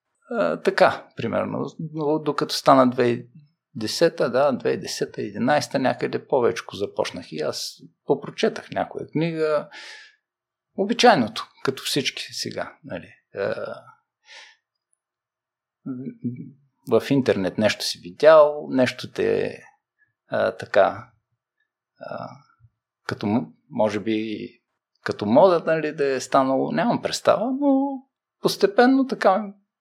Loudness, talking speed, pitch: -22 LUFS, 95 wpm, 165 Hz